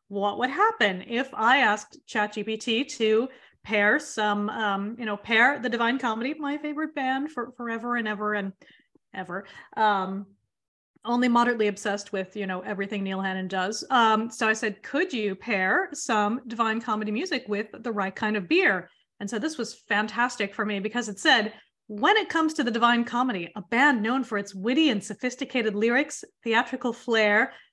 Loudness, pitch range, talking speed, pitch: -25 LUFS, 210-250 Hz, 180 wpm, 225 Hz